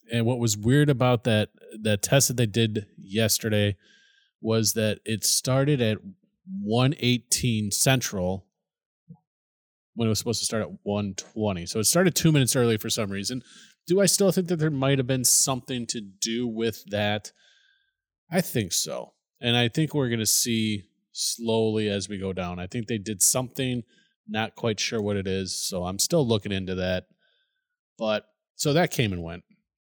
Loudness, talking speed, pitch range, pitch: -25 LUFS, 175 wpm, 105-140 Hz, 115 Hz